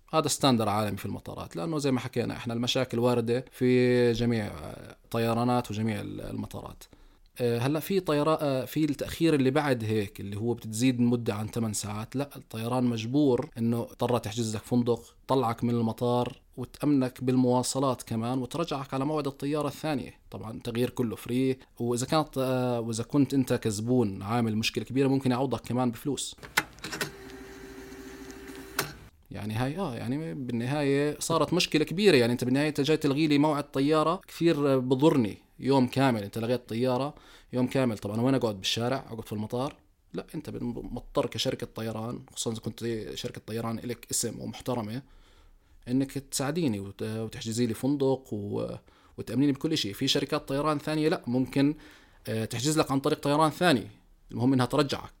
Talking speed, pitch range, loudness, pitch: 150 wpm, 115-140 Hz, -28 LUFS, 125 Hz